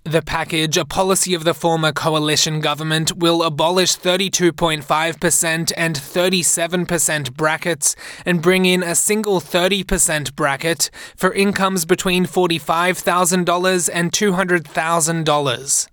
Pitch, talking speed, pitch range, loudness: 170 Hz, 105 wpm, 160-185 Hz, -17 LUFS